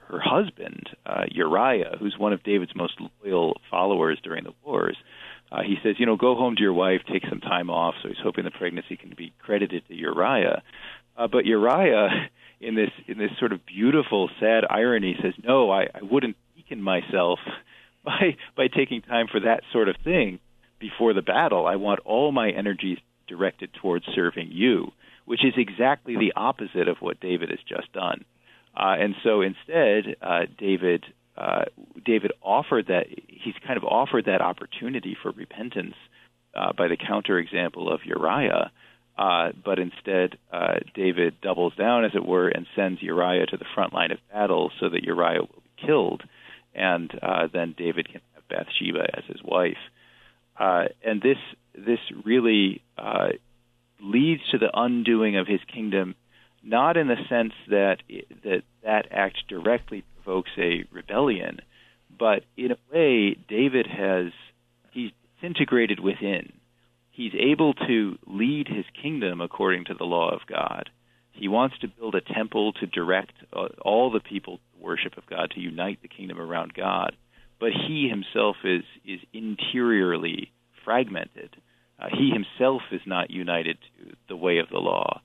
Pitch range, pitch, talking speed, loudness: 90-120 Hz, 100 Hz, 165 wpm, -25 LUFS